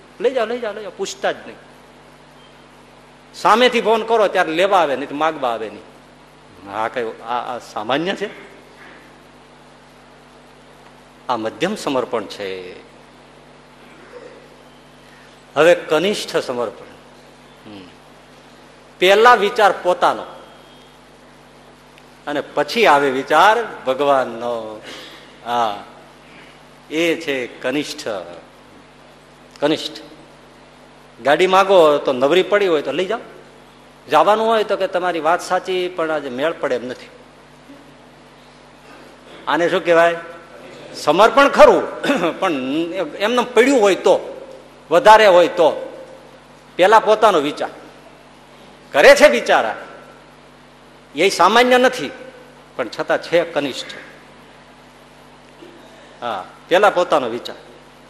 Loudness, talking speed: -16 LUFS, 100 wpm